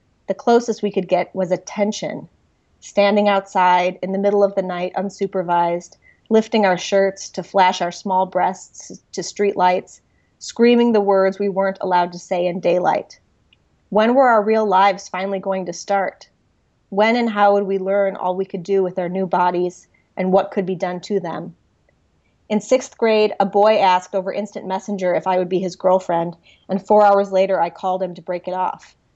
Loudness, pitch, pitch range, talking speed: -18 LUFS, 195 Hz, 185-205 Hz, 190 wpm